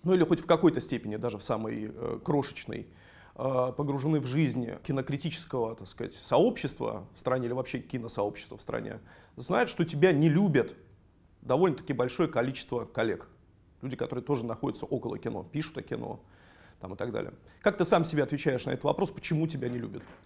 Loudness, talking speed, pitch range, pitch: -30 LUFS, 180 wpm, 115-160 Hz, 130 Hz